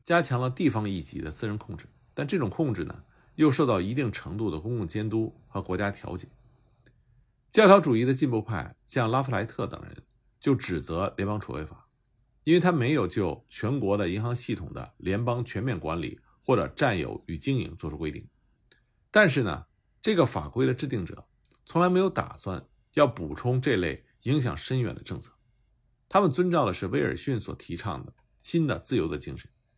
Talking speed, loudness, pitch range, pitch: 280 characters per minute, -27 LUFS, 100-135 Hz, 120 Hz